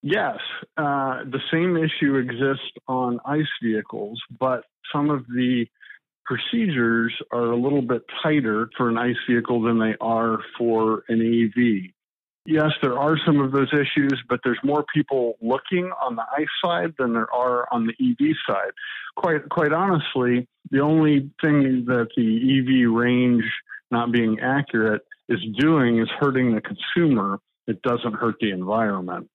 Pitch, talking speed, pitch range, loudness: 125 Hz, 155 wpm, 115-145 Hz, -22 LUFS